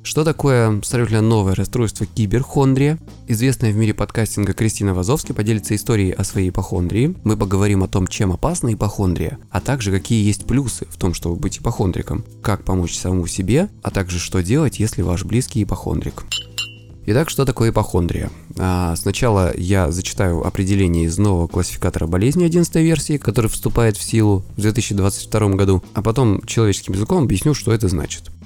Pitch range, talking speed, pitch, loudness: 95-115 Hz, 160 wpm, 105 Hz, -19 LUFS